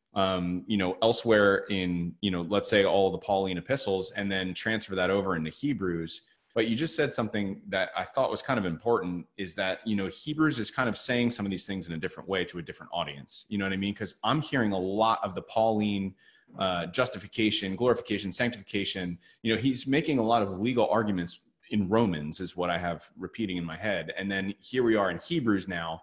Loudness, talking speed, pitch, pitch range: -29 LUFS, 225 wpm, 100 Hz, 95-115 Hz